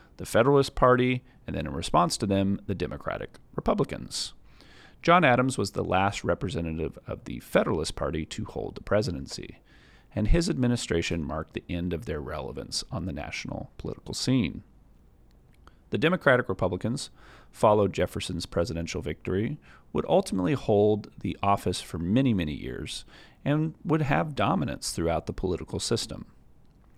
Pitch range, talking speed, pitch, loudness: 85-125 Hz, 140 wpm, 100 Hz, -28 LUFS